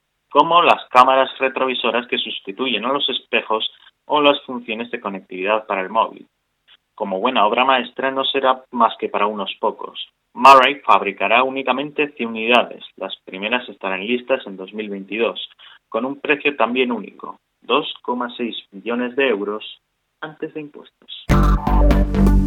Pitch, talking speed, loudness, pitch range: 125 Hz, 135 wpm, -18 LUFS, 110-135 Hz